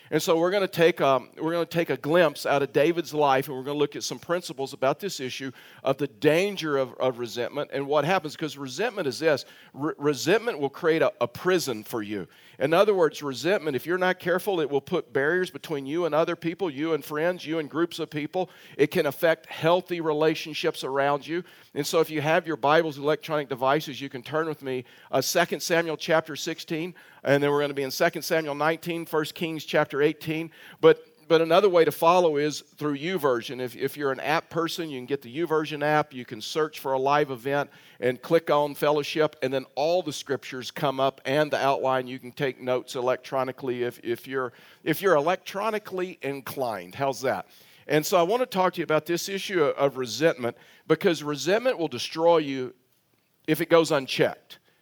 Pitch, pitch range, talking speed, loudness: 150 Hz, 135-170 Hz, 210 wpm, -26 LUFS